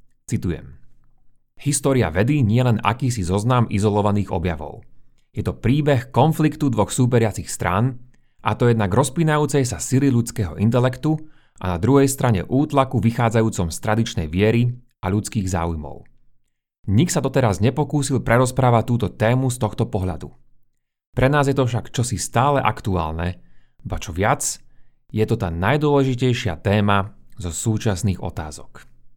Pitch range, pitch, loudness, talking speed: 100-130 Hz, 115 Hz, -20 LUFS, 135 wpm